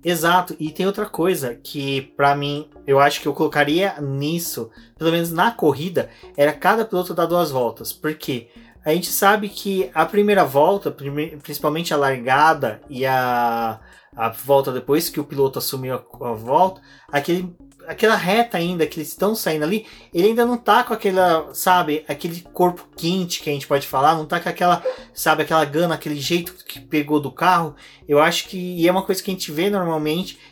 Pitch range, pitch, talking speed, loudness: 145-180 Hz, 160 Hz, 190 wpm, -20 LUFS